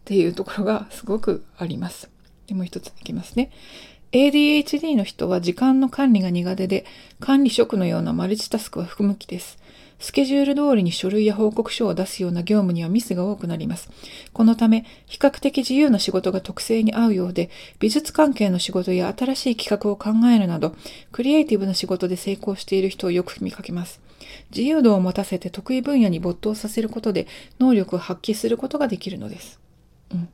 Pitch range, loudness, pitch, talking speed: 185-245 Hz, -21 LUFS, 210 Hz, 390 characters per minute